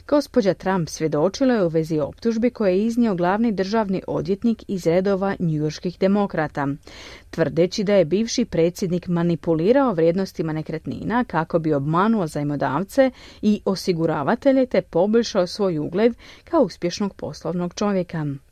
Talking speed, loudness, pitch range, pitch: 125 wpm, -21 LUFS, 165-220 Hz, 185 Hz